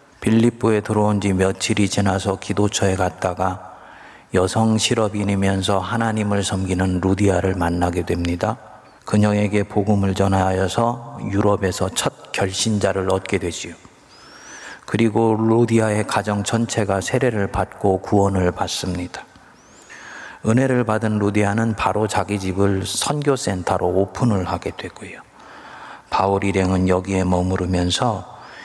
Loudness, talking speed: -20 LUFS, 285 characters per minute